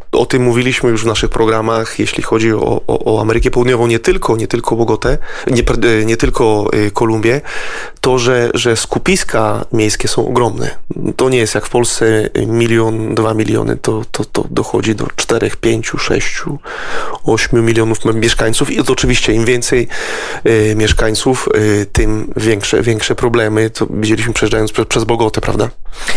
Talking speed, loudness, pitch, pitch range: 150 wpm, -13 LUFS, 115 Hz, 110-120 Hz